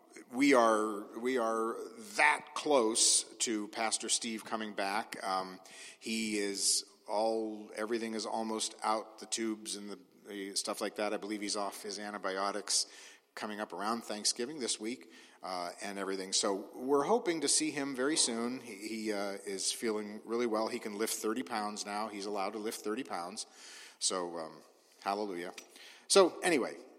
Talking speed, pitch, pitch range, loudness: 165 wpm, 110 Hz, 100-115 Hz, -33 LUFS